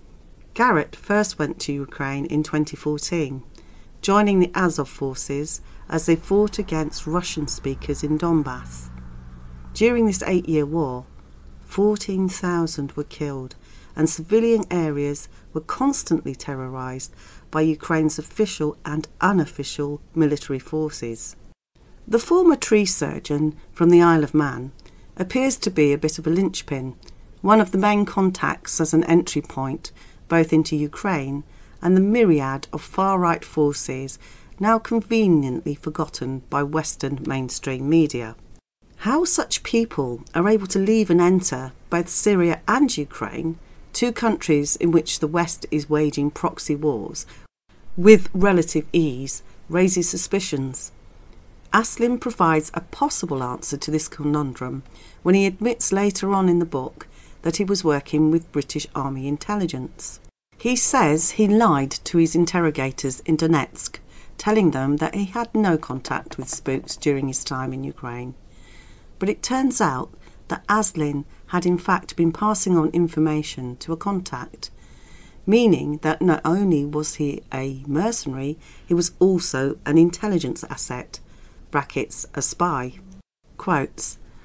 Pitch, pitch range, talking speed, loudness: 155 Hz, 140-185 Hz, 135 wpm, -21 LUFS